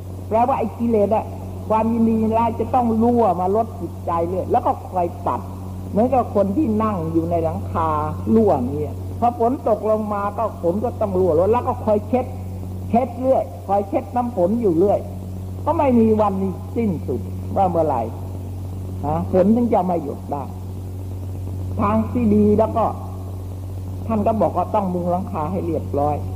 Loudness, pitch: -20 LUFS, 95 Hz